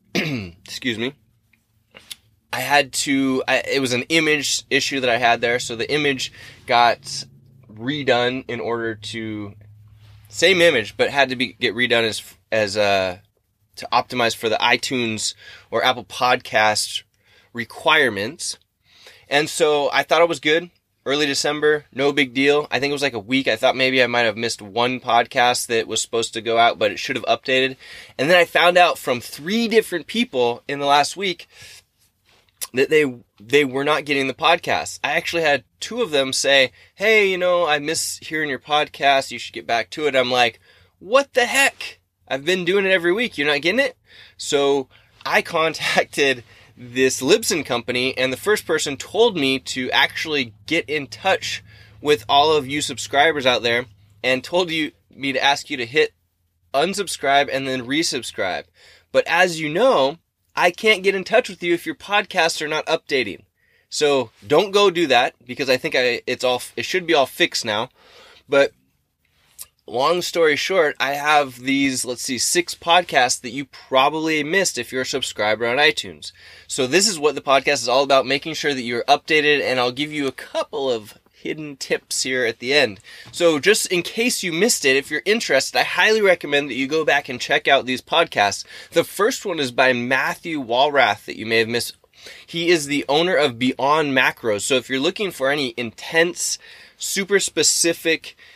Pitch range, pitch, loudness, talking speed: 120-160 Hz, 135 Hz, -19 LUFS, 190 wpm